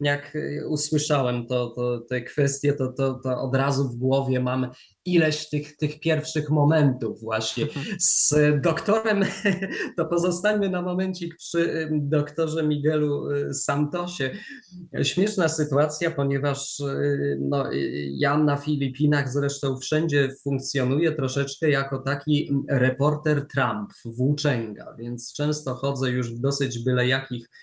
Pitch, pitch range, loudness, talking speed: 145 Hz, 130-155 Hz, -24 LUFS, 115 wpm